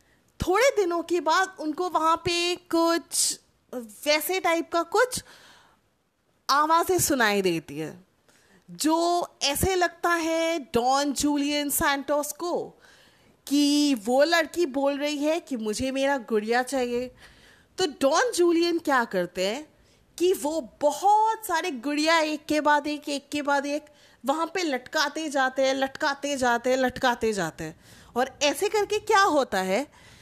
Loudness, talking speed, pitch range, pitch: -25 LUFS, 140 wpm, 260-335 Hz, 295 Hz